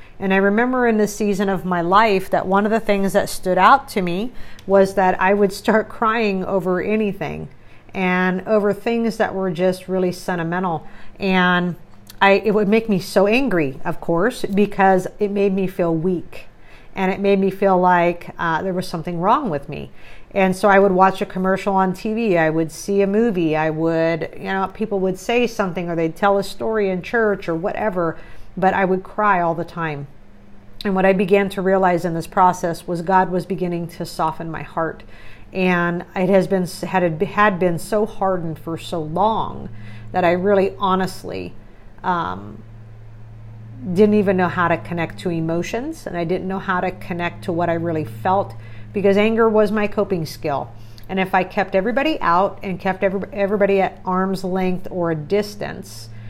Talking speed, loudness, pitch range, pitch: 190 wpm, -19 LUFS, 170-200 Hz, 185 Hz